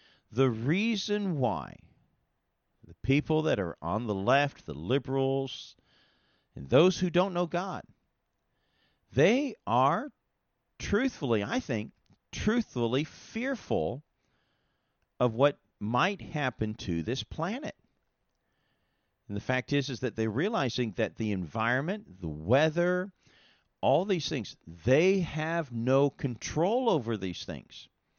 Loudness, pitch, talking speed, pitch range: -30 LUFS, 130 Hz, 115 wpm, 110-170 Hz